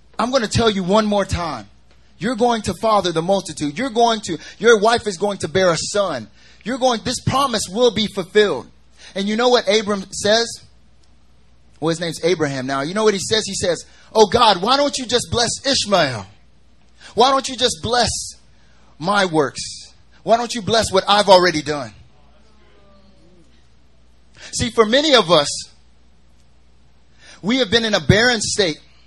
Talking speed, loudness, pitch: 175 wpm, -17 LUFS, 200 Hz